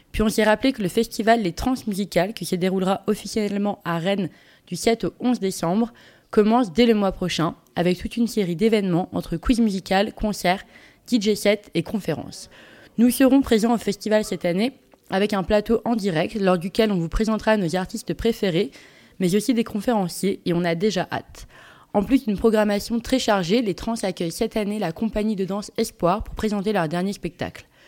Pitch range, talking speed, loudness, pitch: 180-225 Hz, 190 wpm, -22 LUFS, 205 Hz